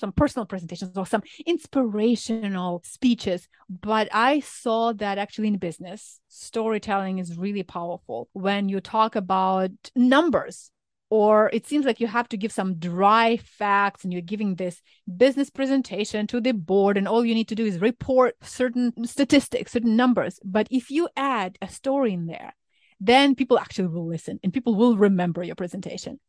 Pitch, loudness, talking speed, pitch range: 215 Hz, -23 LUFS, 170 wpm, 190-245 Hz